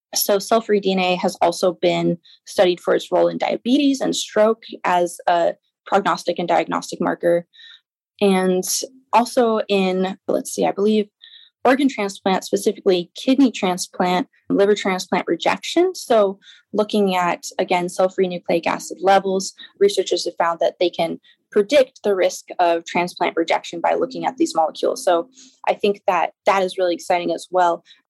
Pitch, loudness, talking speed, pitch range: 195 Hz, -20 LUFS, 155 wpm, 180-220 Hz